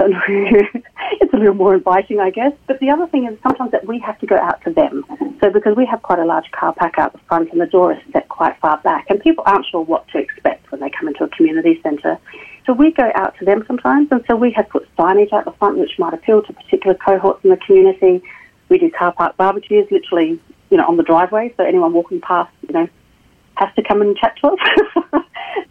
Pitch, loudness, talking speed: 240 Hz, -15 LUFS, 245 wpm